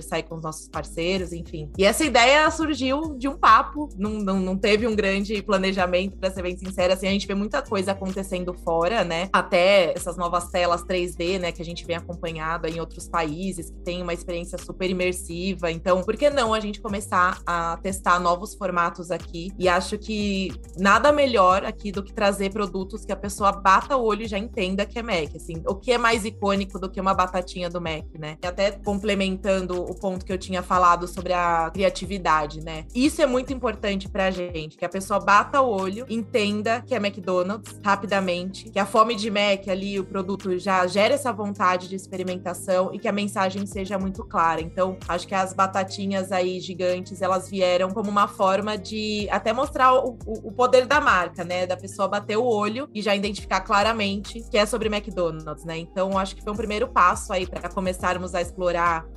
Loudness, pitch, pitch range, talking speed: -23 LUFS, 190 Hz, 180-210 Hz, 200 wpm